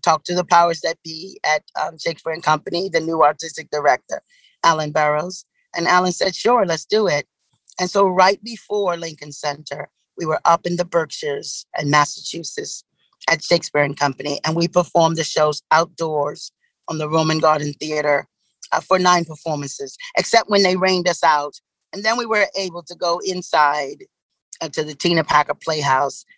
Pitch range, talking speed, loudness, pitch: 150-185 Hz, 175 wpm, -19 LUFS, 165 Hz